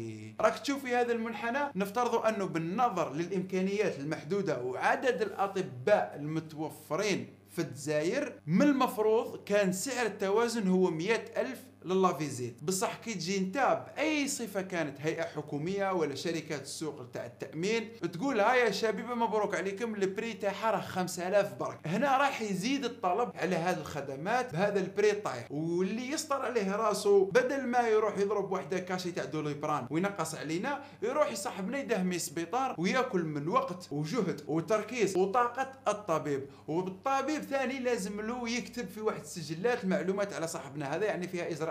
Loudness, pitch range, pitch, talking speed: -32 LUFS, 165-235 Hz, 200 Hz, 140 wpm